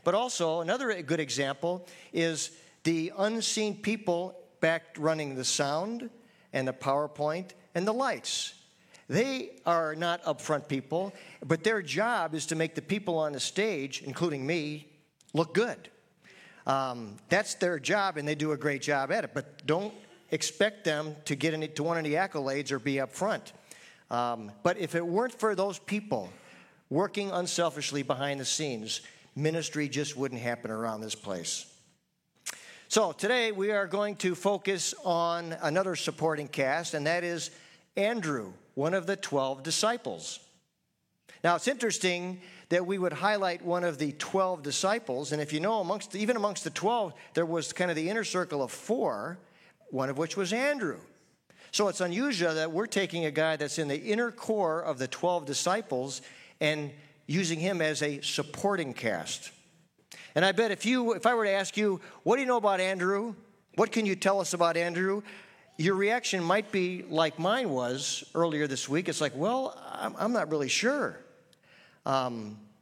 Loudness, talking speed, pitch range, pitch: -30 LUFS, 170 wpm, 150-195 Hz, 170 Hz